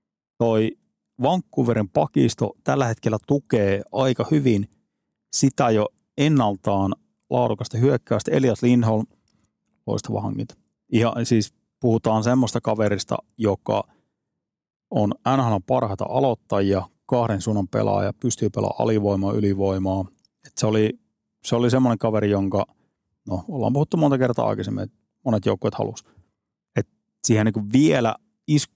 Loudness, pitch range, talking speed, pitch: -22 LUFS, 105-130 Hz, 115 wpm, 115 Hz